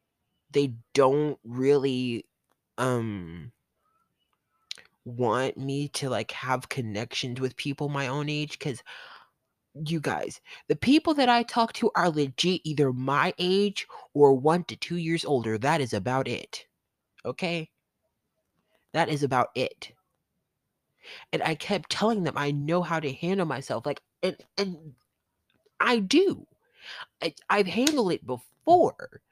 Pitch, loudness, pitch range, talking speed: 145 Hz, -27 LUFS, 130-175 Hz, 135 wpm